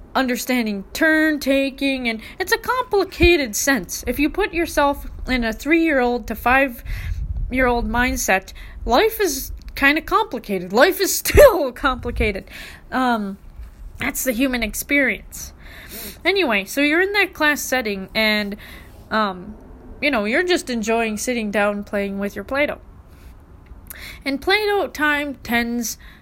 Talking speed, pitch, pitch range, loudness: 125 wpm, 260 Hz, 220-310 Hz, -19 LUFS